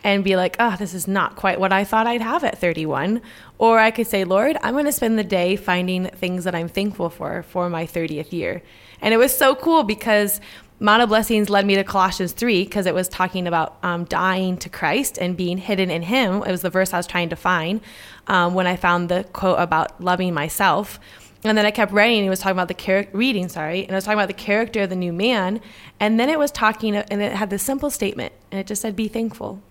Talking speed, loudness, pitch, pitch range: 250 wpm, -20 LUFS, 195 Hz, 180-215 Hz